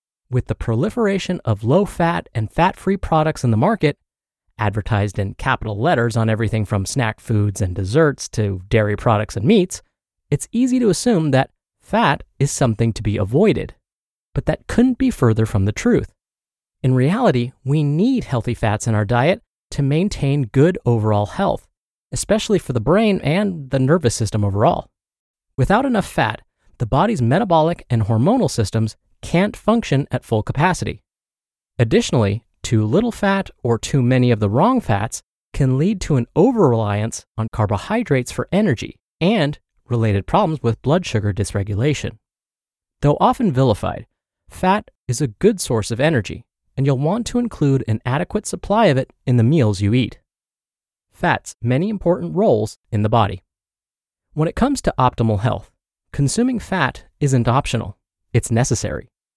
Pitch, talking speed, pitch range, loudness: 125 Hz, 160 wpm, 110-170 Hz, -19 LUFS